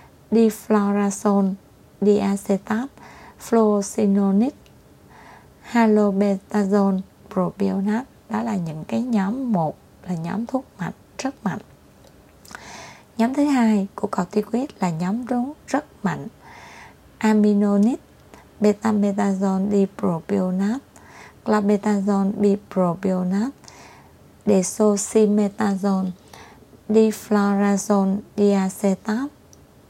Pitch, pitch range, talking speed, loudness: 205 Hz, 195-220 Hz, 70 wpm, -21 LUFS